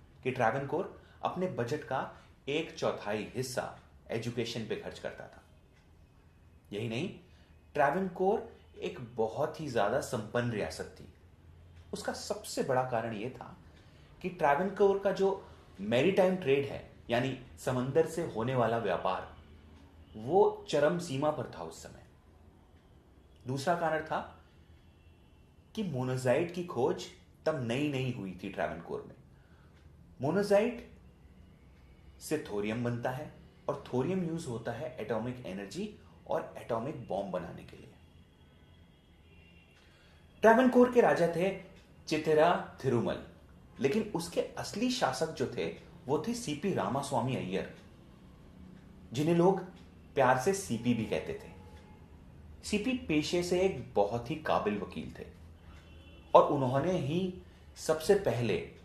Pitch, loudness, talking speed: 120 Hz, -32 LUFS, 125 wpm